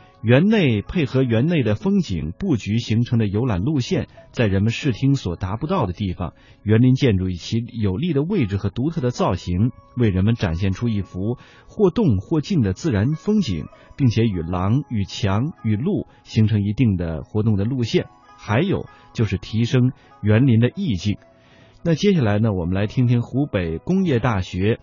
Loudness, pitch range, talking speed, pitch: -21 LUFS, 100-135 Hz, 265 characters per minute, 115 Hz